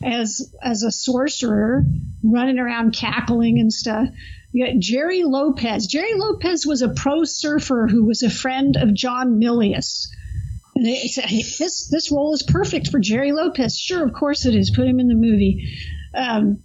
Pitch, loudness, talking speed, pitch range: 245 Hz, -19 LUFS, 175 wpm, 225-285 Hz